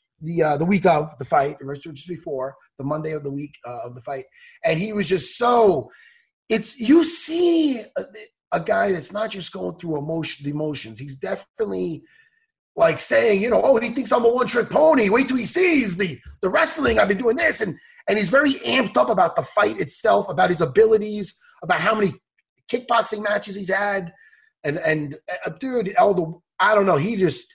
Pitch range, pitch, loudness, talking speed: 155-260 Hz, 205 Hz, -20 LUFS, 205 wpm